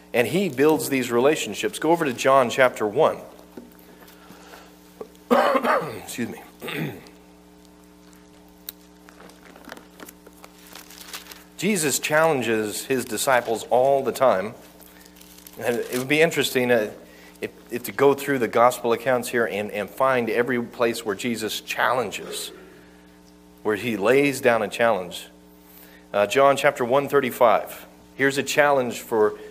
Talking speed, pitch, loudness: 115 wpm, 105 Hz, -22 LUFS